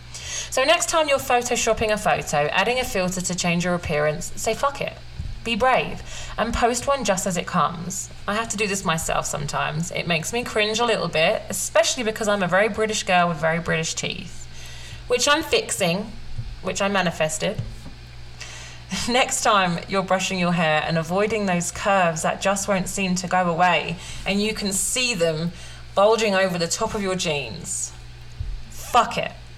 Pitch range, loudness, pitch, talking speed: 160-220 Hz, -22 LUFS, 185 Hz, 180 wpm